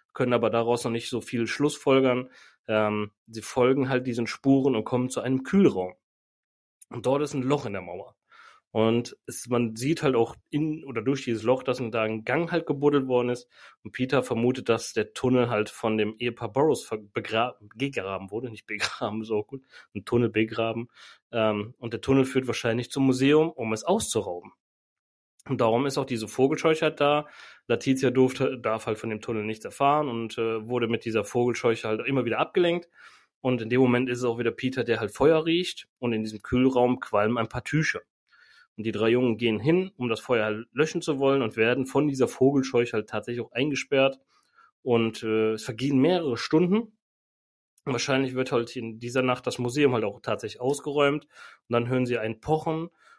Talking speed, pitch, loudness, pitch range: 195 wpm, 125 Hz, -26 LUFS, 115-135 Hz